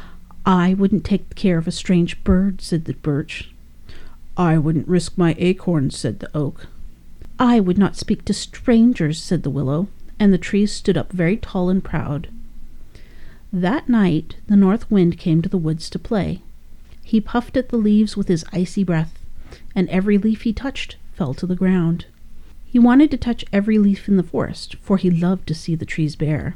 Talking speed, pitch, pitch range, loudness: 190 wpm, 180 Hz, 155-200 Hz, -19 LUFS